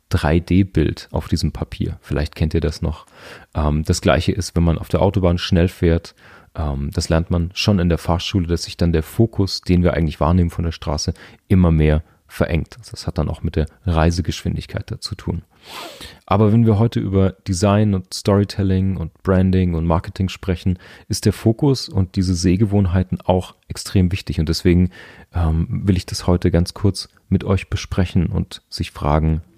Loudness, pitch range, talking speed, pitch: -19 LUFS, 80-95 Hz, 175 wpm, 90 Hz